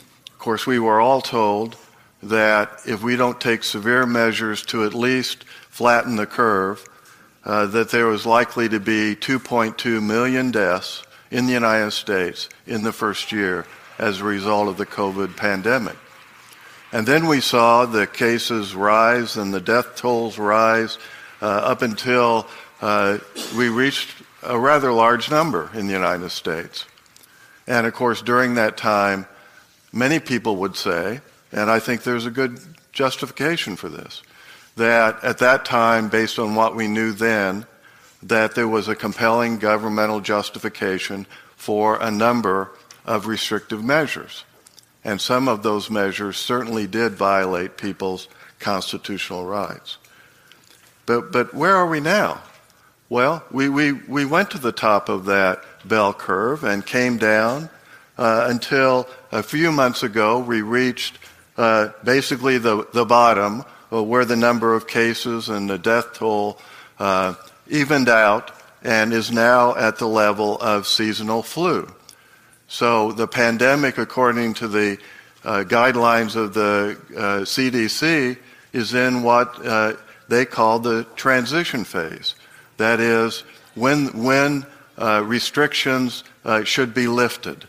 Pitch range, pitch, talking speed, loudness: 105-125 Hz, 115 Hz, 145 wpm, -19 LUFS